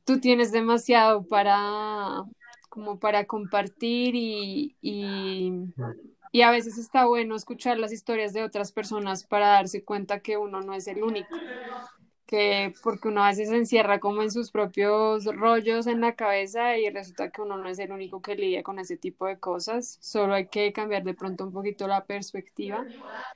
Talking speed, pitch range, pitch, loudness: 175 wpm, 200-230 Hz, 210 Hz, -26 LUFS